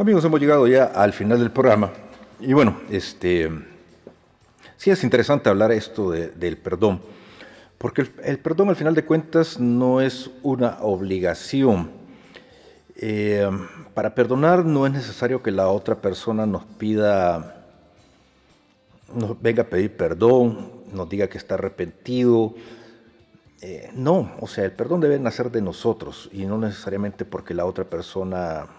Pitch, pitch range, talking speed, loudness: 115 Hz, 100-130 Hz, 145 wpm, -21 LUFS